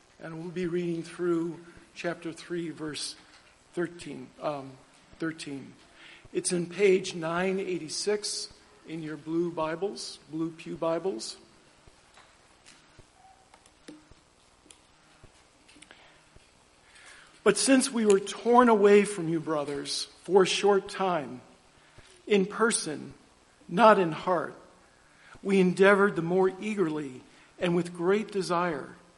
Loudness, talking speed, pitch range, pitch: -27 LUFS, 105 wpm, 160-195 Hz, 175 Hz